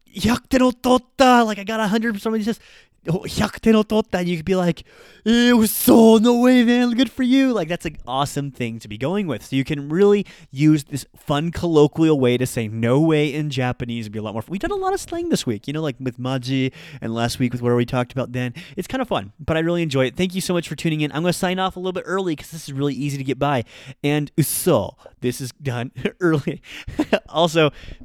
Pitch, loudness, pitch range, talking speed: 160 Hz, -20 LUFS, 135-210 Hz, 240 wpm